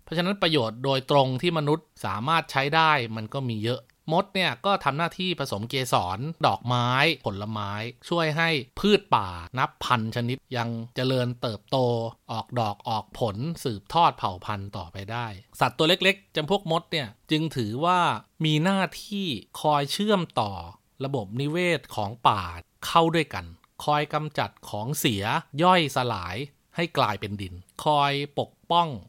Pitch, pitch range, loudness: 135 Hz, 115-160 Hz, -26 LUFS